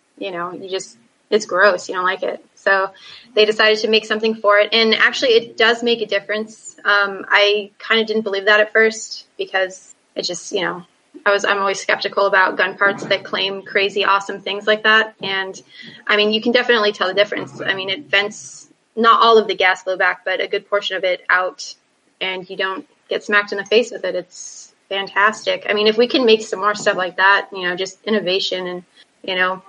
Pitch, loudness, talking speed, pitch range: 200 Hz, -17 LUFS, 225 wpm, 190-220 Hz